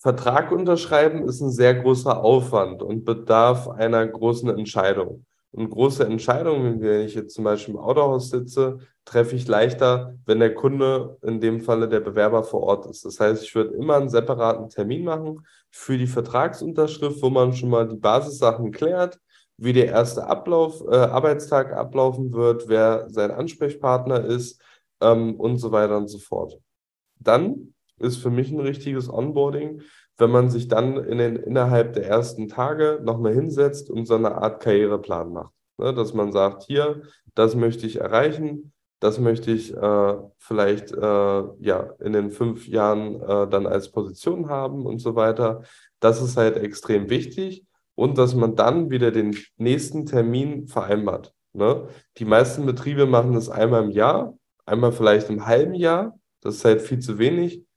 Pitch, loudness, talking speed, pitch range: 120 Hz, -21 LUFS, 165 wpm, 110-135 Hz